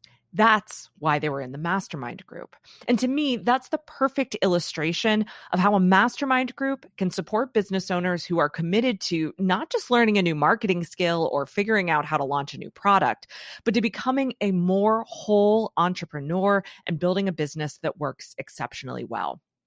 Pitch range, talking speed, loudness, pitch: 170-230 Hz, 180 wpm, -24 LUFS, 195 Hz